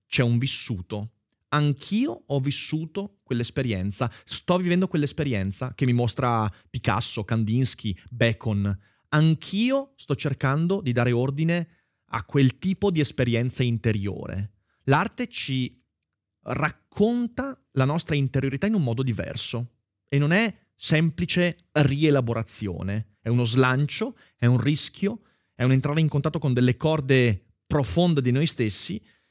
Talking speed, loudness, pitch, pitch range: 125 wpm, -25 LUFS, 135 Hz, 115-160 Hz